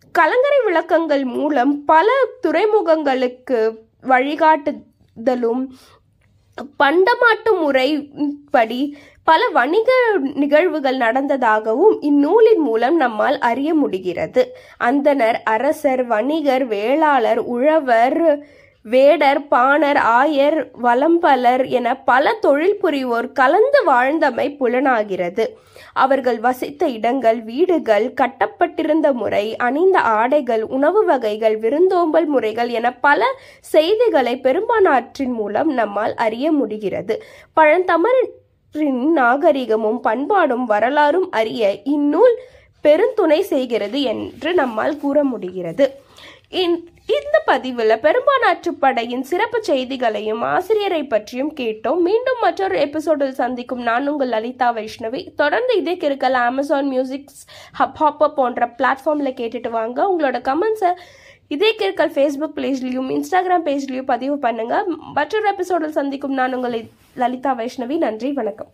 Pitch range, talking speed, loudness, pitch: 245-330 Hz, 95 wpm, -17 LUFS, 285 Hz